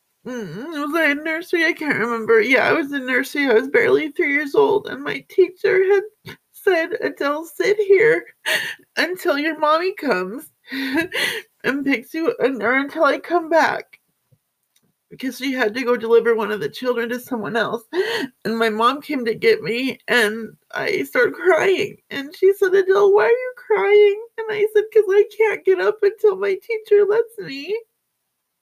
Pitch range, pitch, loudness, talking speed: 250-410 Hz, 325 Hz, -19 LUFS, 175 wpm